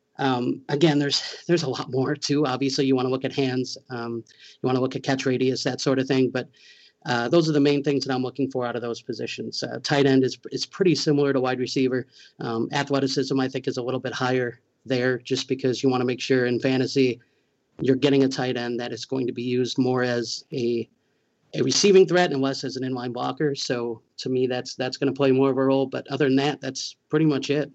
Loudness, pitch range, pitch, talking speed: -24 LUFS, 125-140 Hz, 130 Hz, 245 wpm